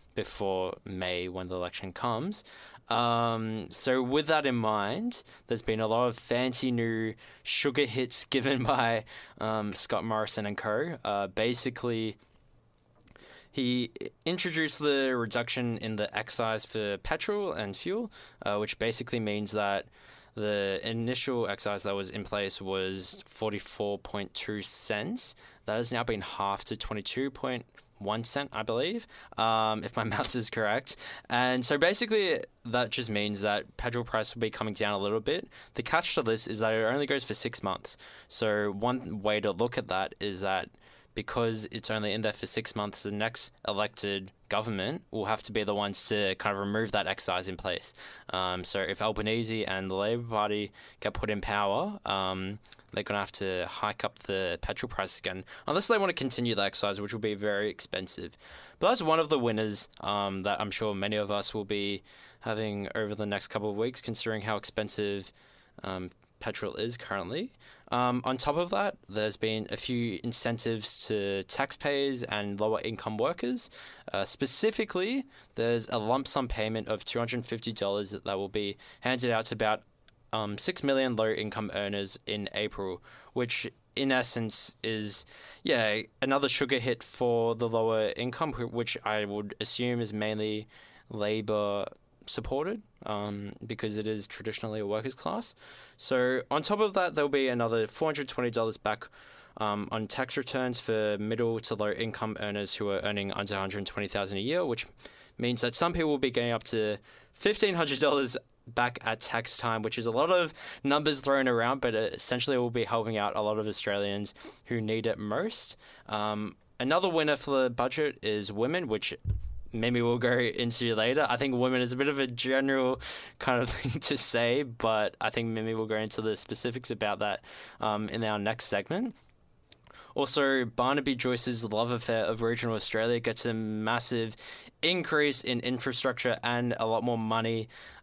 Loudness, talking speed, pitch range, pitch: -31 LUFS, 175 wpm, 105-125 Hz, 110 Hz